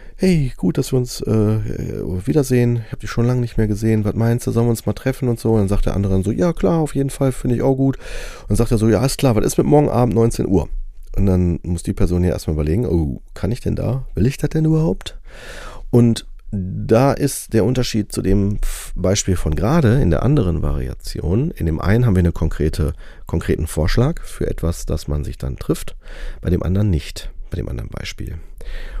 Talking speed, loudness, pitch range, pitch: 230 wpm, -19 LUFS, 90-125 Hz, 105 Hz